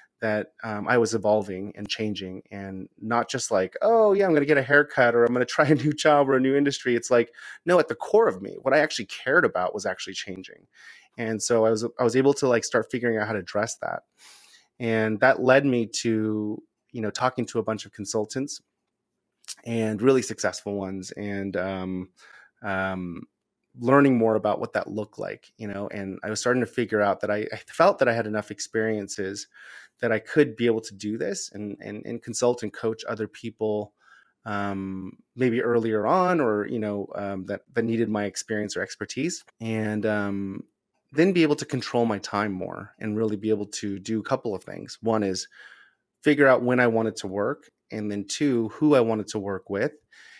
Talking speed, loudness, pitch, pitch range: 210 wpm, -25 LUFS, 110 Hz, 105-125 Hz